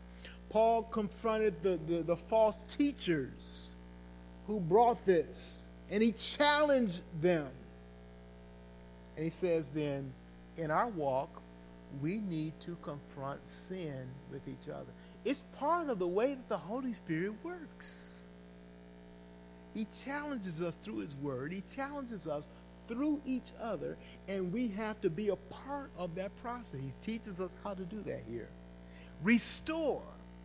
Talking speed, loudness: 140 wpm, -36 LUFS